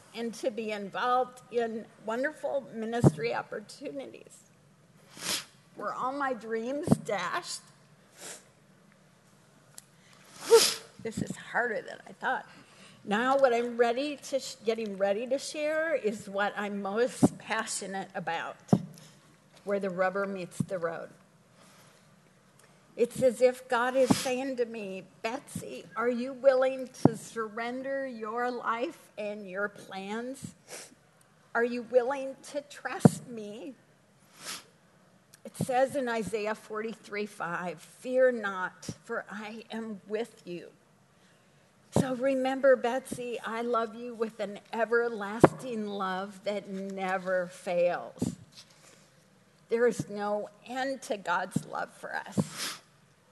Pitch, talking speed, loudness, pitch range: 225 Hz, 115 wpm, -31 LUFS, 195-255 Hz